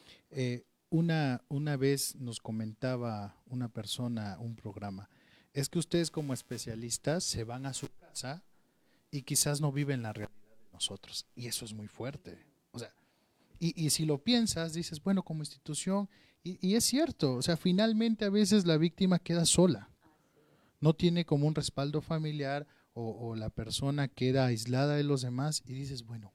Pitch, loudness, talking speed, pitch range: 140 Hz, -33 LUFS, 170 wpm, 120-165 Hz